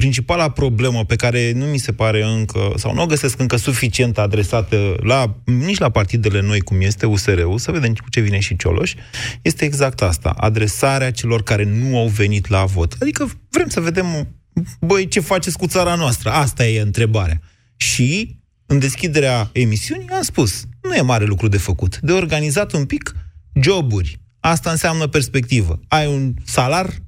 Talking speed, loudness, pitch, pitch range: 175 wpm, -17 LUFS, 120 Hz, 105-145 Hz